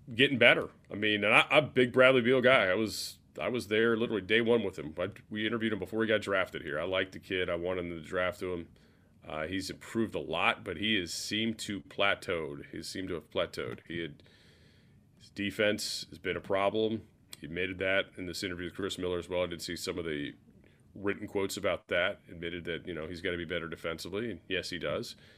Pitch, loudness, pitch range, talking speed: 100 Hz, -31 LUFS, 90-110 Hz, 235 wpm